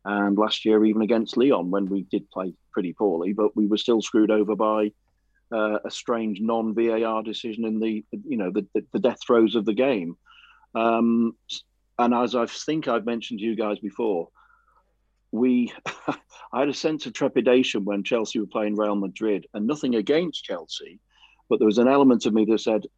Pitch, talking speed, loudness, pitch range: 110 Hz, 190 wpm, -24 LUFS, 105-115 Hz